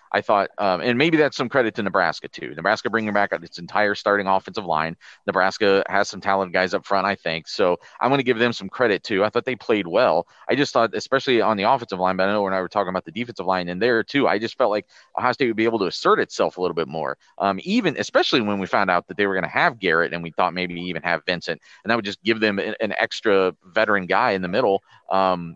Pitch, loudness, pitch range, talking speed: 95 Hz, -21 LUFS, 90-110 Hz, 270 wpm